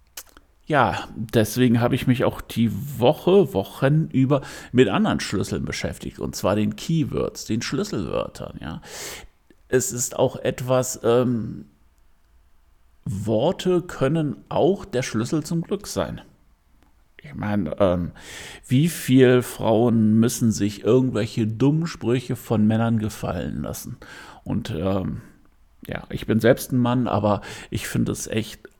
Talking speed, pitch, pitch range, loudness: 130 wpm, 120 Hz, 105-130 Hz, -22 LUFS